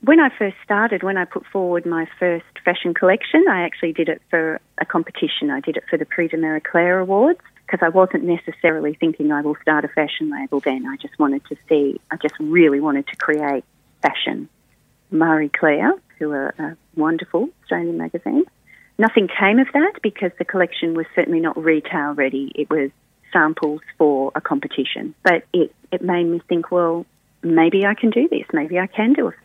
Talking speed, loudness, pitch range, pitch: 195 wpm, -19 LUFS, 155-195 Hz, 170 Hz